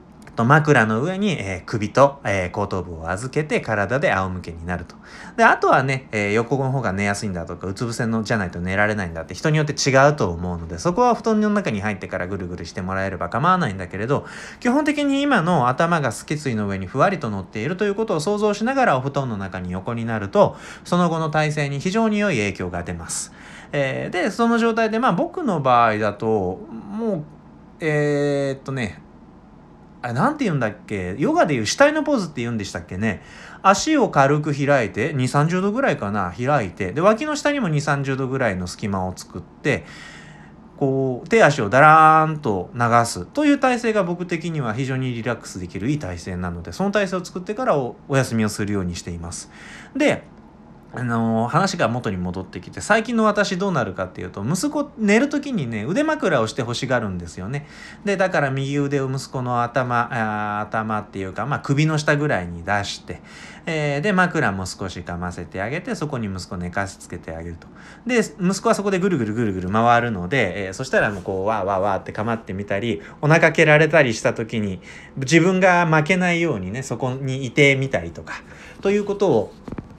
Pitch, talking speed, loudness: 130 Hz, 390 characters per minute, -21 LUFS